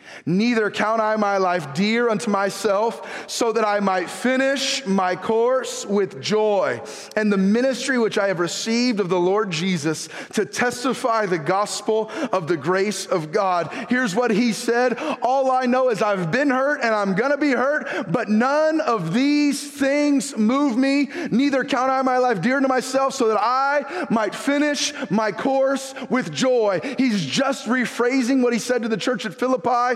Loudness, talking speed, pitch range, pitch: -21 LUFS, 175 wpm, 205-265 Hz, 235 Hz